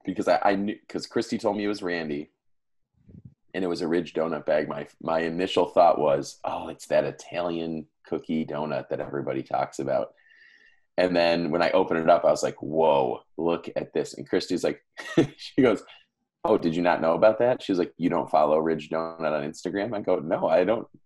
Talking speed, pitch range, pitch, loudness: 210 wpm, 80-90 Hz, 85 Hz, -26 LUFS